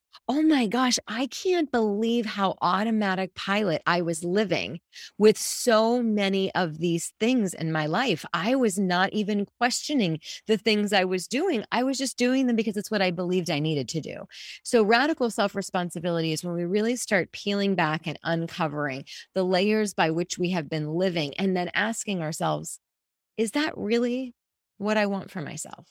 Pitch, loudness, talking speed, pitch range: 200 Hz, -26 LUFS, 180 wpm, 175-230 Hz